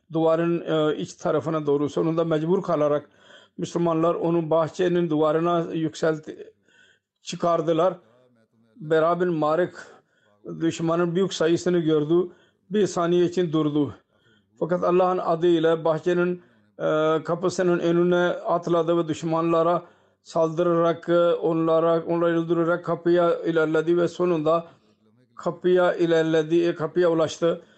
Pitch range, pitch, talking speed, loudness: 160-175 Hz, 170 Hz, 95 wpm, -23 LUFS